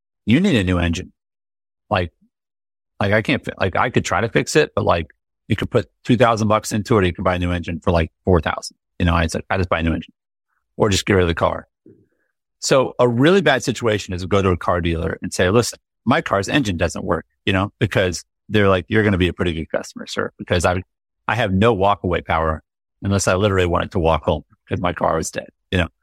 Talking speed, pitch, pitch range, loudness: 240 wpm, 95 Hz, 85-110 Hz, -19 LUFS